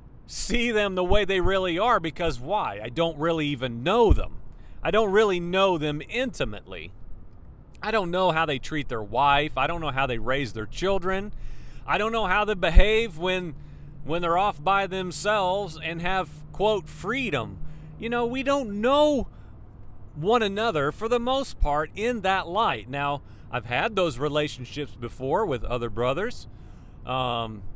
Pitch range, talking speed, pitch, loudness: 135-210 Hz, 165 wpm, 170 Hz, -25 LUFS